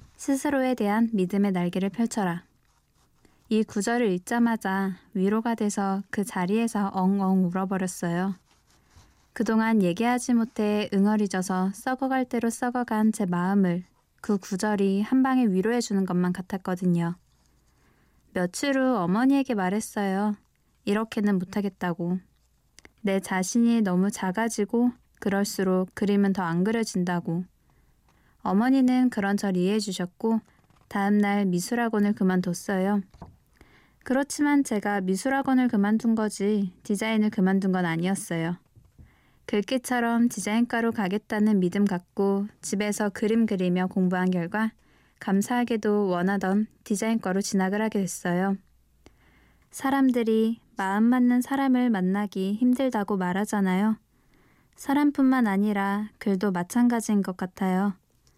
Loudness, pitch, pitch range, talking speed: -25 LUFS, 205 Hz, 190-230 Hz, 285 characters per minute